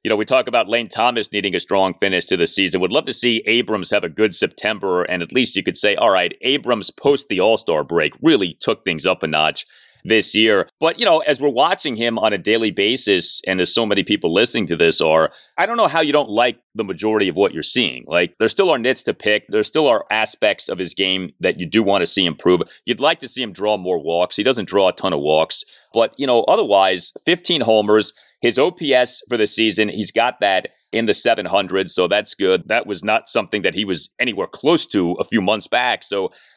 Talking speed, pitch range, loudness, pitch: 245 wpm, 95-125 Hz, -17 LUFS, 110 Hz